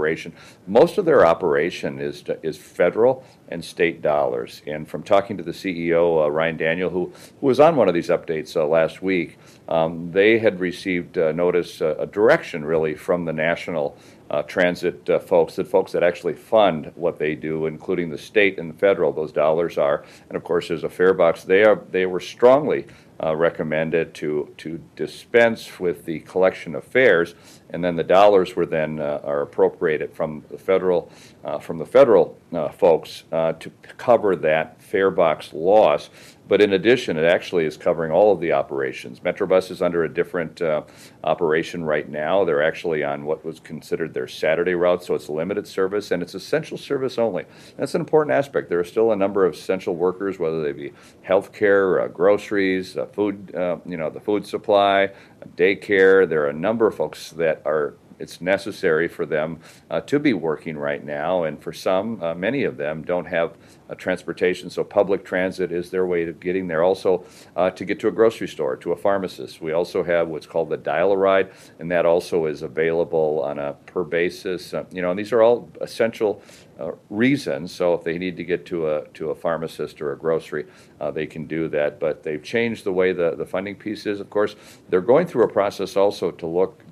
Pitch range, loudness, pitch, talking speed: 80-110 Hz, -21 LUFS, 90 Hz, 200 wpm